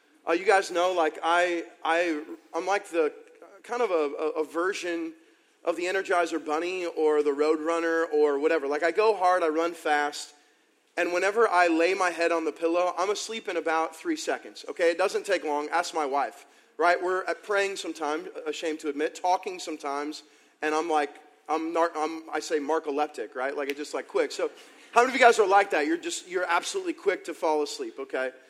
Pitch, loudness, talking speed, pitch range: 165 Hz, -27 LUFS, 205 wpm, 155-190 Hz